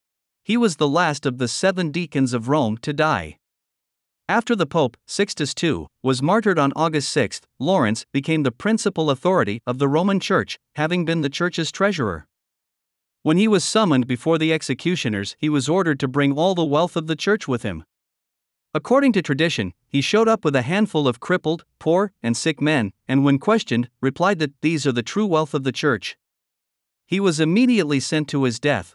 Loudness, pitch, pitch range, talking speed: -21 LUFS, 155 Hz, 130-180 Hz, 190 wpm